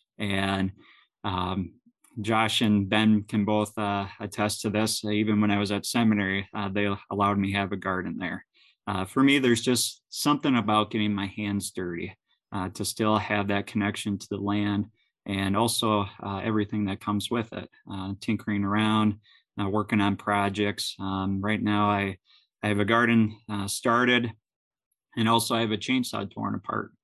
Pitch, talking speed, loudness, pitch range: 105 Hz, 175 wpm, -26 LUFS, 100-110 Hz